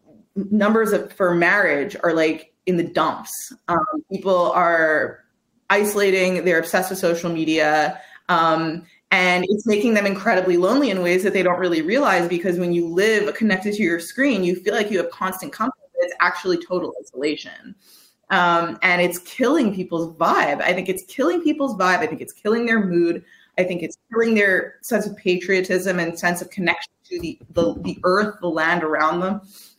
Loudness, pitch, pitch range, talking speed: -20 LUFS, 185 Hz, 170-205 Hz, 185 wpm